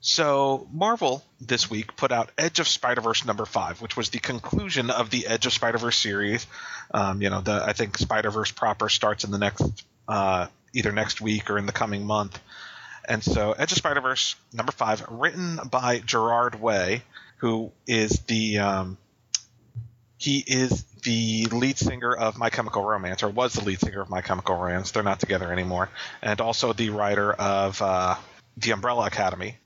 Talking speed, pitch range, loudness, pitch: 185 wpm, 100-120 Hz, -25 LUFS, 110 Hz